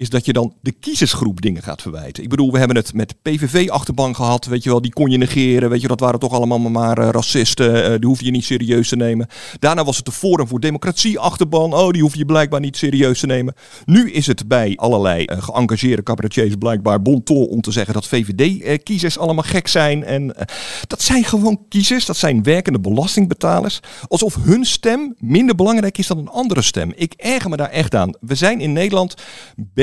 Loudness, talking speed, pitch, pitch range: -16 LUFS, 215 wpm, 135 Hz, 115-165 Hz